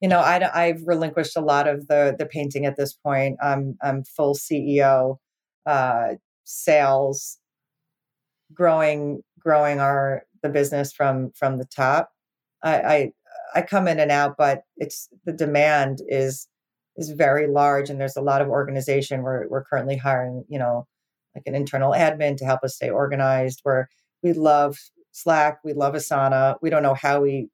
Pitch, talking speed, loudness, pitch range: 140 Hz, 170 wpm, -22 LUFS, 135-150 Hz